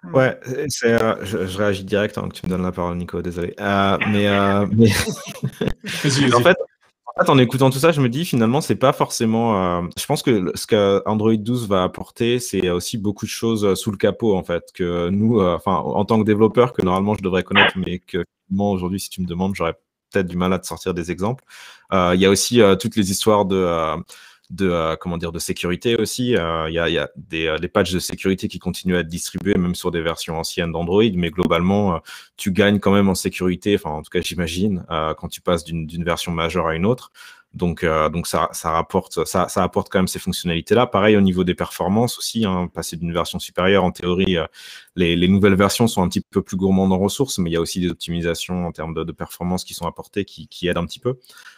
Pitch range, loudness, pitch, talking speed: 85-105 Hz, -20 LUFS, 95 Hz, 240 wpm